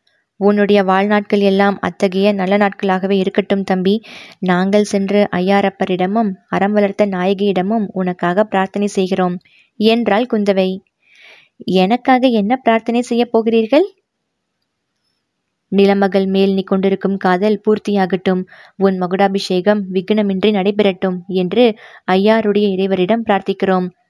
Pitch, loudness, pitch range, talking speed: 200 Hz, -15 LUFS, 190-210 Hz, 90 wpm